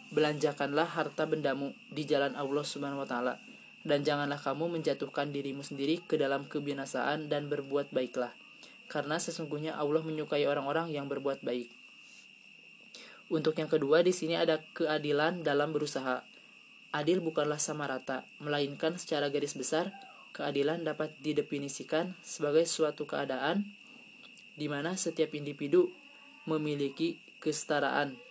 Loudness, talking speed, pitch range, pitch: -33 LUFS, 125 wpm, 145-170 Hz, 155 Hz